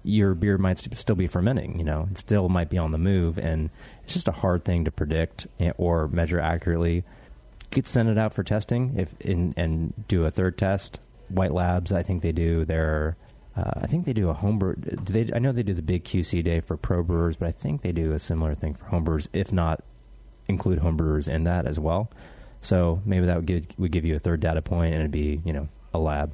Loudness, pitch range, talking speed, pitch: -26 LUFS, 80-95 Hz, 230 wpm, 90 Hz